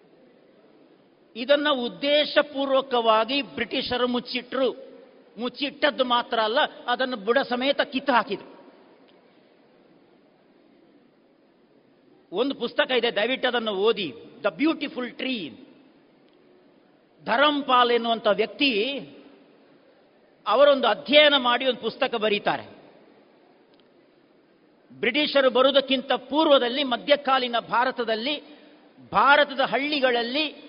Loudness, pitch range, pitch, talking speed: -23 LUFS, 240-285 Hz, 260 Hz, 70 wpm